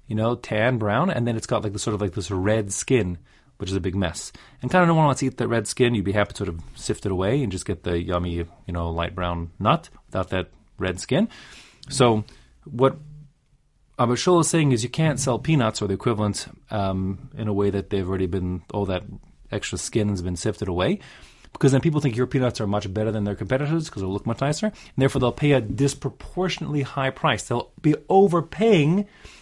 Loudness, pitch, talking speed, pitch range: -23 LUFS, 110 Hz, 230 wpm, 100-135 Hz